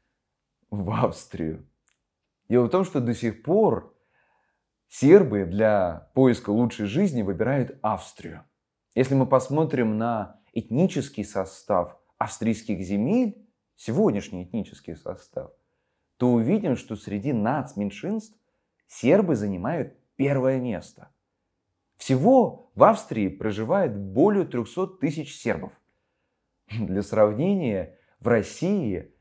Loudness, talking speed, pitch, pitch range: -24 LUFS, 100 wpm, 120 Hz, 105-155 Hz